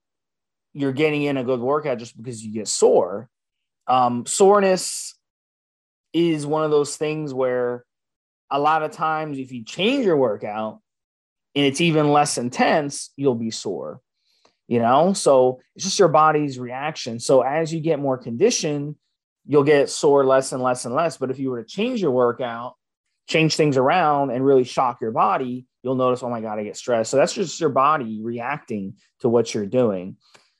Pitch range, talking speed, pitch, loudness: 120-155 Hz, 180 wpm, 135 Hz, -21 LUFS